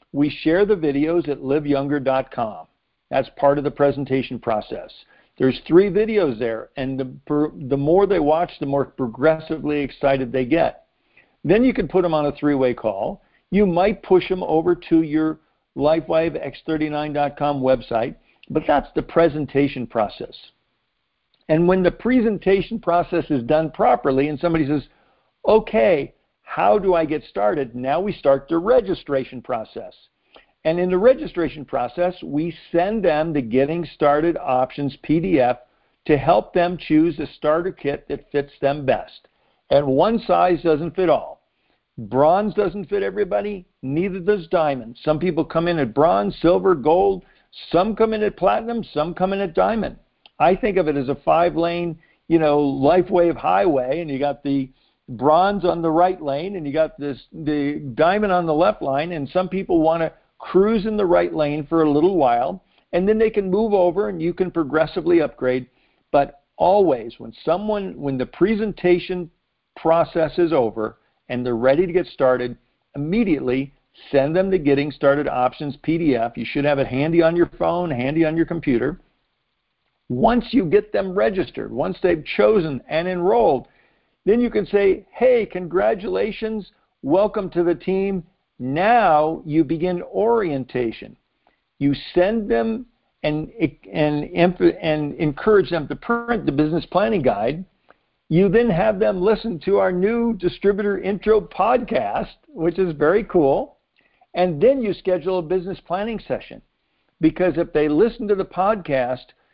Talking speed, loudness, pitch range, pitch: 160 wpm, -20 LUFS, 145-190 Hz, 165 Hz